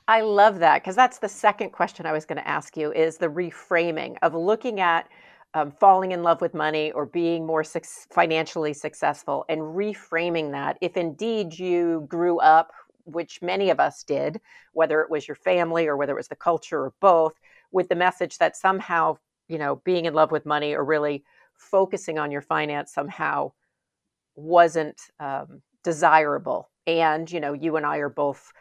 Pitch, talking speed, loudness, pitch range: 165 Hz, 185 wpm, -23 LUFS, 155-180 Hz